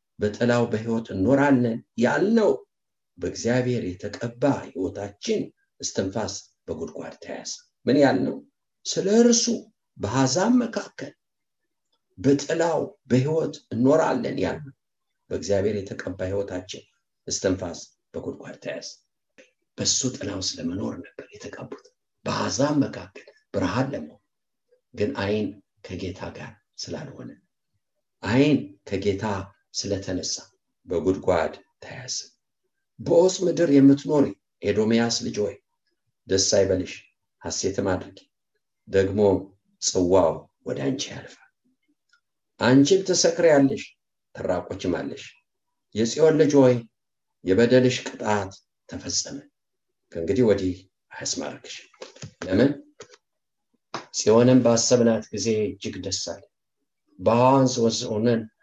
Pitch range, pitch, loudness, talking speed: 105-180 Hz, 125 Hz, -23 LUFS, 85 wpm